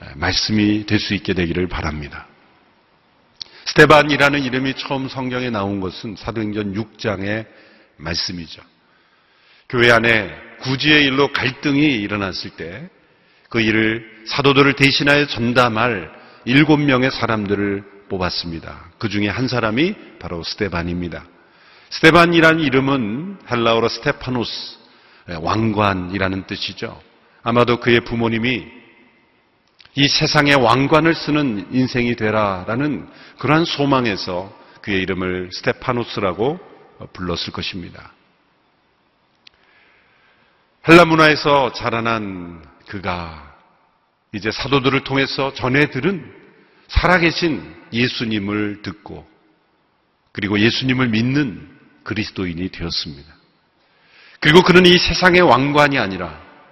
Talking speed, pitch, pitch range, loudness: 260 characters per minute, 115 Hz, 100-135 Hz, -17 LUFS